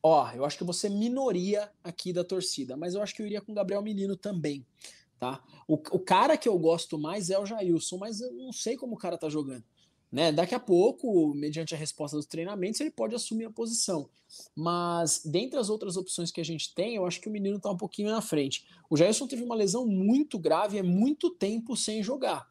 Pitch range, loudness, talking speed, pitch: 165-215 Hz, -30 LUFS, 225 wpm, 190 Hz